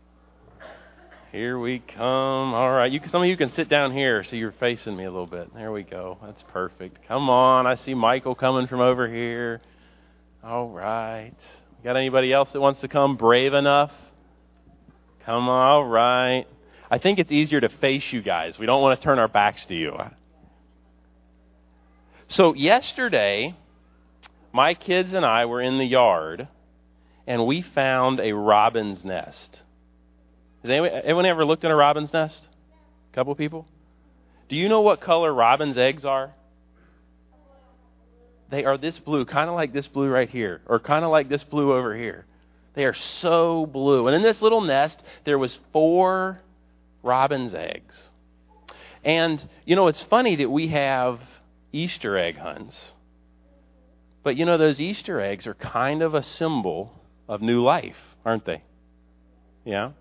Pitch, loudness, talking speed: 125 Hz, -22 LUFS, 165 wpm